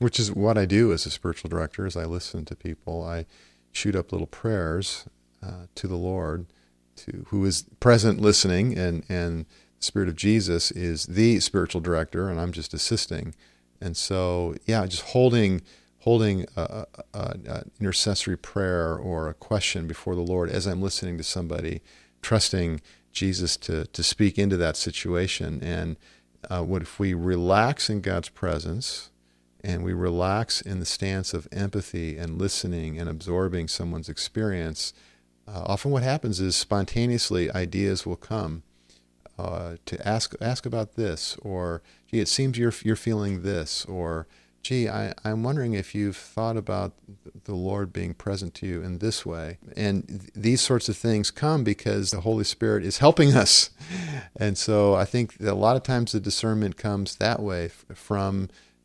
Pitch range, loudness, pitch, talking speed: 85-105 Hz, -26 LUFS, 95 Hz, 170 wpm